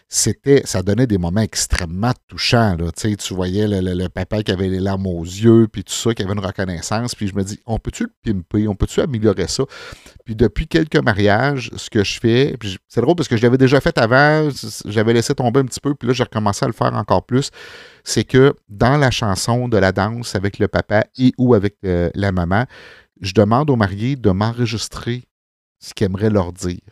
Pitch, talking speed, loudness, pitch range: 110 Hz, 225 wpm, -18 LUFS, 95-120 Hz